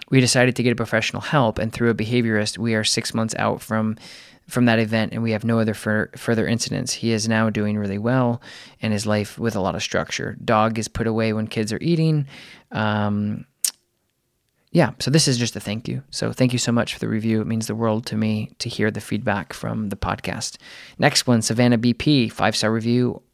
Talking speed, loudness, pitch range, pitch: 225 wpm, -21 LUFS, 110-120 Hz, 110 Hz